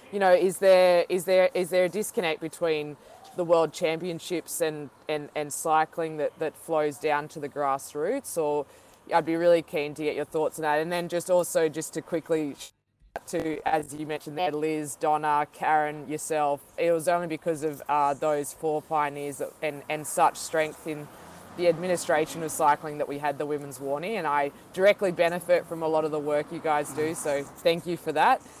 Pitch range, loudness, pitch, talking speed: 150-170 Hz, -27 LUFS, 155 Hz, 200 wpm